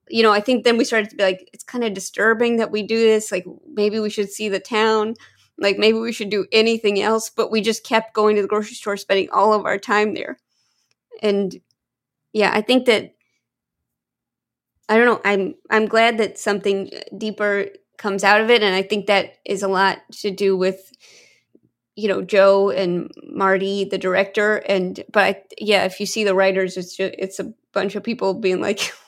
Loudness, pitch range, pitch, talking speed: -19 LUFS, 195-225 Hz, 210 Hz, 205 wpm